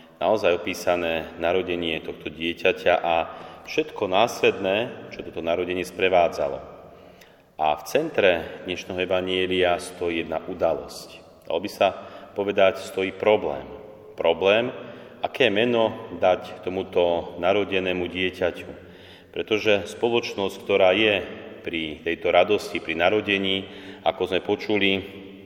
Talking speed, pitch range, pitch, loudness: 105 wpm, 85-95 Hz, 90 Hz, -24 LUFS